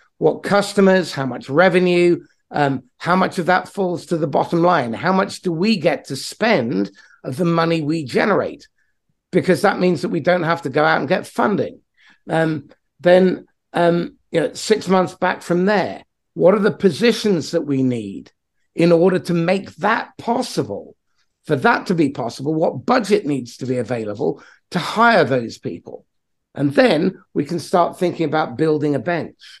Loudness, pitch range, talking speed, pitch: -18 LUFS, 150-185 Hz, 180 wpm, 170 Hz